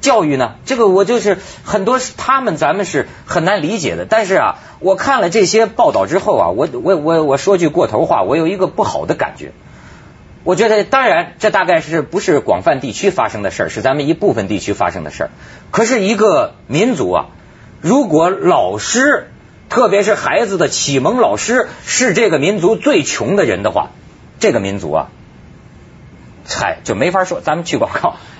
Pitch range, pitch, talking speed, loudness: 180-240 Hz, 200 Hz, 275 characters per minute, -14 LUFS